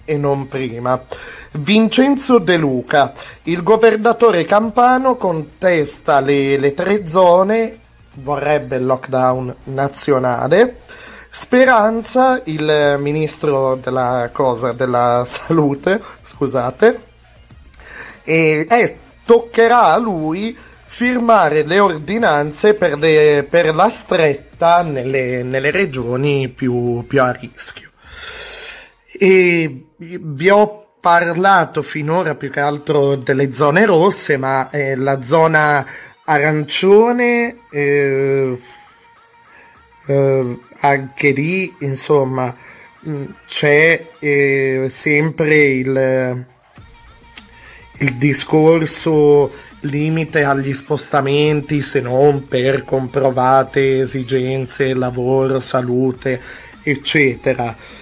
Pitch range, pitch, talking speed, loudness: 135-180 Hz, 145 Hz, 85 wpm, -15 LUFS